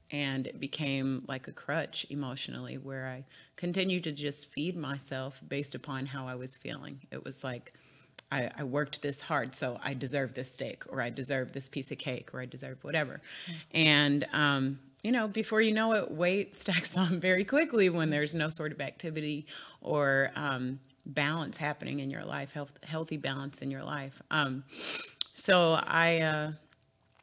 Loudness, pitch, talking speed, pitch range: -32 LUFS, 145 Hz, 175 wpm, 135-160 Hz